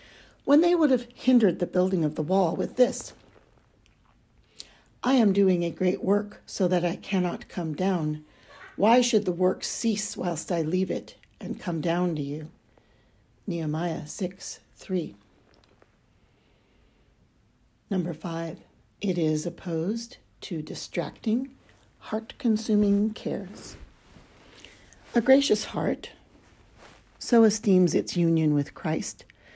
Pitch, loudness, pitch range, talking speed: 185 Hz, -26 LUFS, 165-220 Hz, 120 wpm